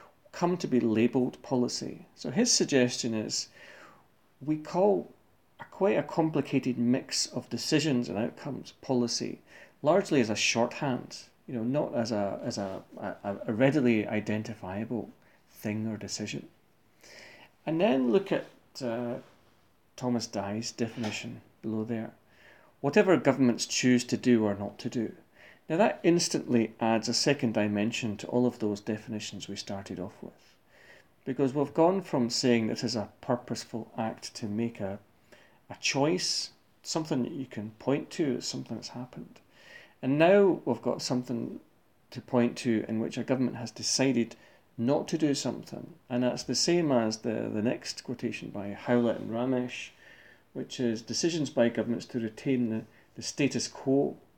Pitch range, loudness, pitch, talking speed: 110-130 Hz, -30 LUFS, 120 Hz, 155 wpm